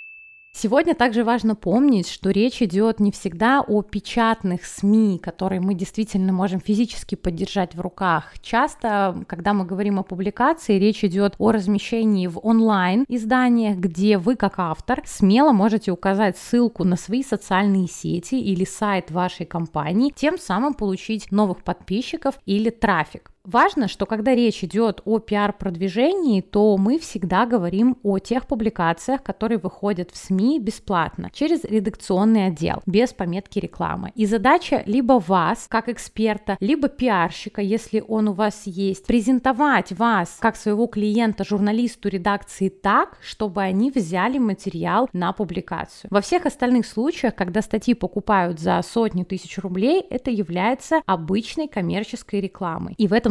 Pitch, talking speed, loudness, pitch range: 210 Hz, 145 wpm, -21 LUFS, 195-235 Hz